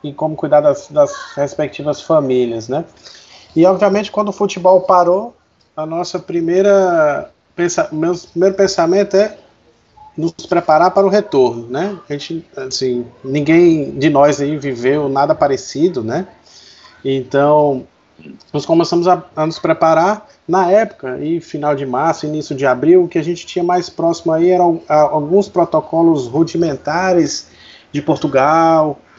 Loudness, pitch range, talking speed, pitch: -14 LUFS, 150-185 Hz, 140 wpm, 165 Hz